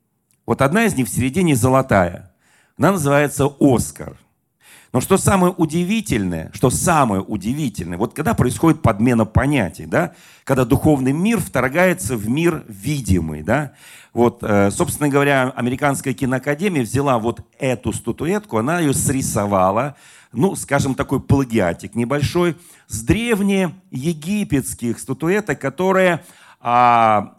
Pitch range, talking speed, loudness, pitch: 115-165 Hz, 115 wpm, -18 LUFS, 135 Hz